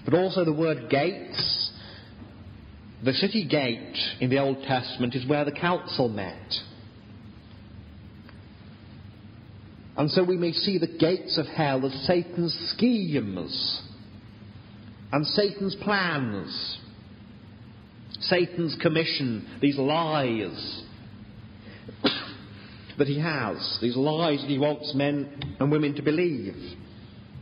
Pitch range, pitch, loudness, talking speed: 105-150 Hz, 120 Hz, -26 LUFS, 105 wpm